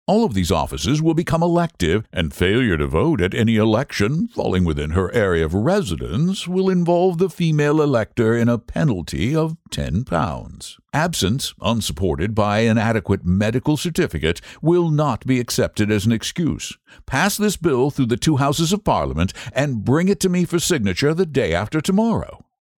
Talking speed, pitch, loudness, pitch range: 170 wpm, 130 Hz, -19 LUFS, 100-170 Hz